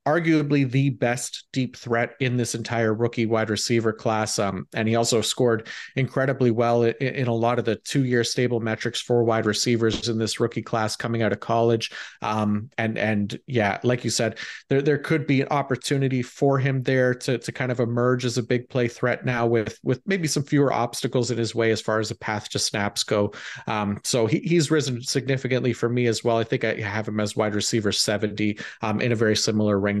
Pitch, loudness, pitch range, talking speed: 120 Hz, -23 LUFS, 110-130 Hz, 220 wpm